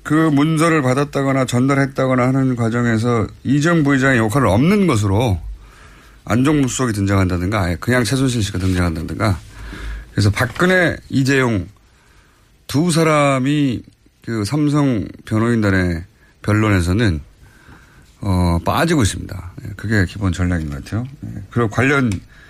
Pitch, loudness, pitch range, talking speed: 115 Hz, -17 LUFS, 100-135 Hz, 295 characters per minute